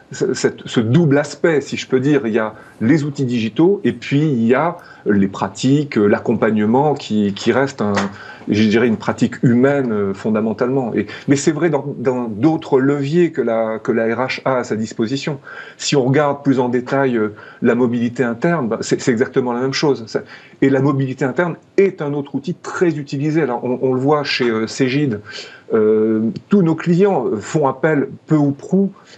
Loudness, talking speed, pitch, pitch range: -17 LUFS, 185 wpm, 135 Hz, 120-150 Hz